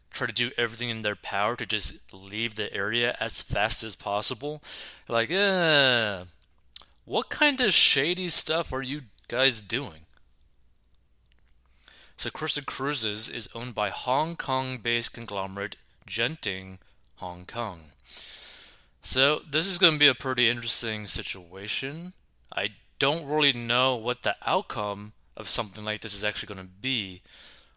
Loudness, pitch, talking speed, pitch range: -25 LUFS, 115 Hz, 140 wpm, 95-130 Hz